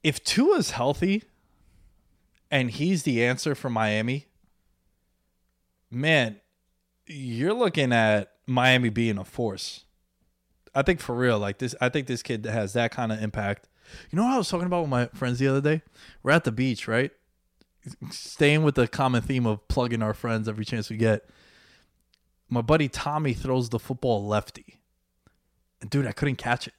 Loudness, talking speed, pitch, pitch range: -25 LUFS, 170 wpm, 120 Hz, 110-140 Hz